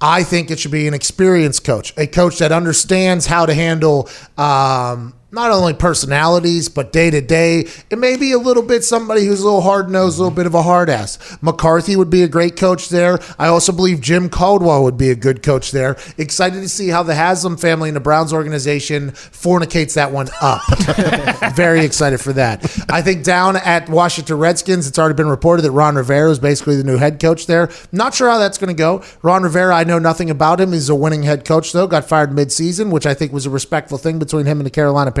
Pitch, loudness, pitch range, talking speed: 165 Hz, -14 LUFS, 150-180 Hz, 230 wpm